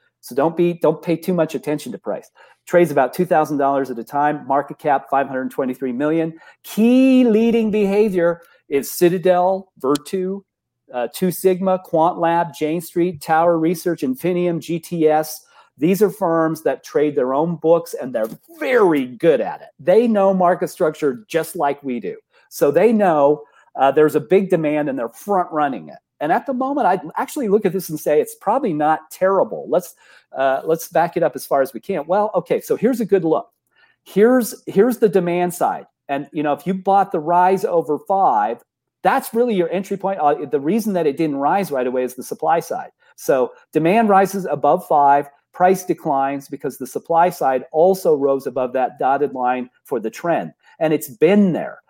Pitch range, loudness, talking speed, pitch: 145-195 Hz, -18 LUFS, 195 wpm, 170 Hz